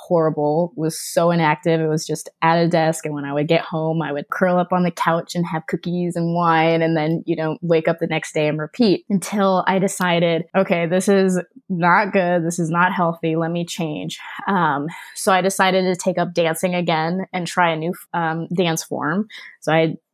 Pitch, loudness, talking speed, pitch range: 170 Hz, -19 LUFS, 215 wpm, 160-180 Hz